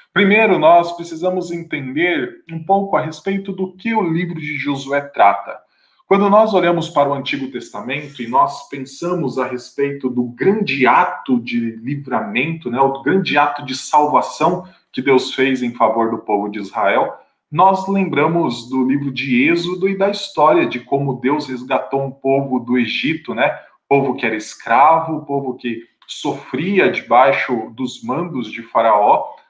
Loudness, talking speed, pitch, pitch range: -17 LUFS, 155 wpm, 140 Hz, 130-175 Hz